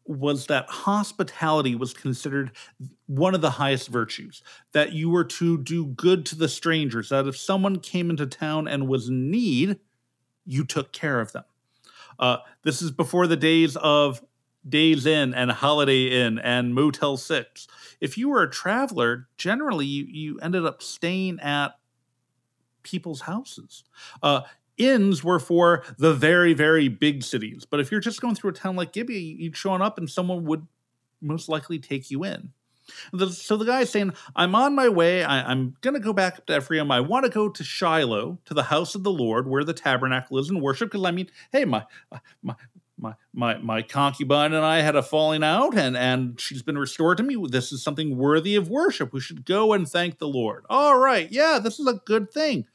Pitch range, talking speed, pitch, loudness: 135-185 Hz, 195 wpm, 155 Hz, -23 LUFS